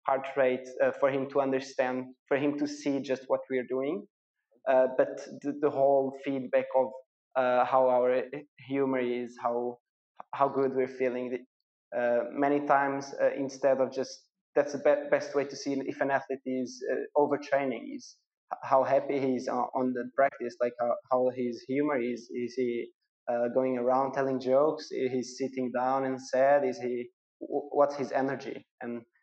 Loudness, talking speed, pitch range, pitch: -30 LUFS, 175 wpm, 125-140 Hz, 130 Hz